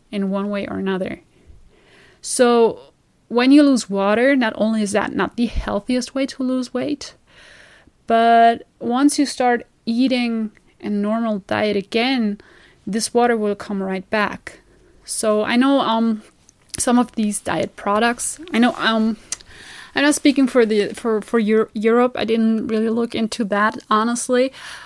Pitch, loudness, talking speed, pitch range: 230 Hz, -19 LUFS, 155 wpm, 215-250 Hz